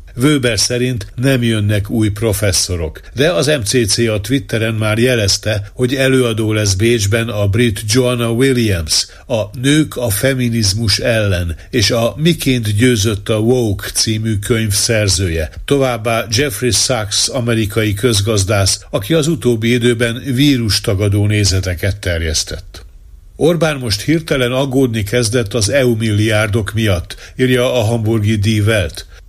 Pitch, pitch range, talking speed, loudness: 115 Hz, 100-125 Hz, 125 wpm, -14 LUFS